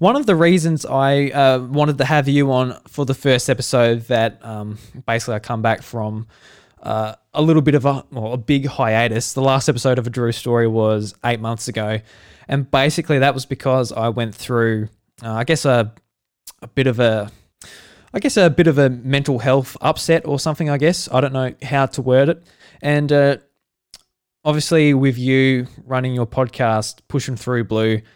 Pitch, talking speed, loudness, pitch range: 130 Hz, 190 wpm, -18 LUFS, 115-140 Hz